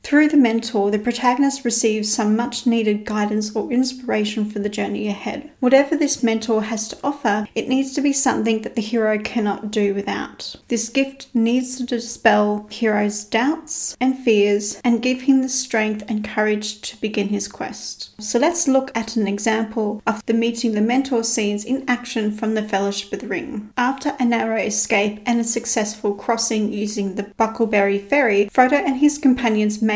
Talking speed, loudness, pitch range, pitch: 180 wpm, -20 LUFS, 210-250 Hz, 225 Hz